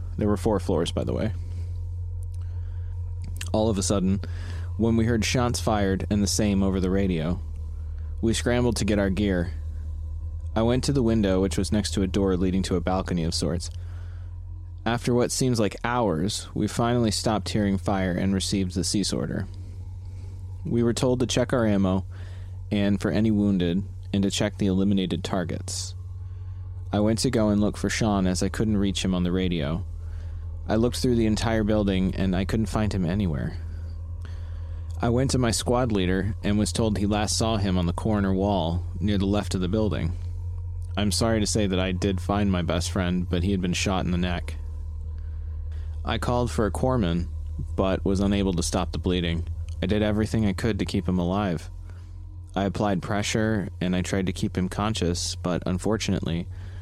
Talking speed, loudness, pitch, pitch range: 190 wpm, -26 LUFS, 95 Hz, 85-105 Hz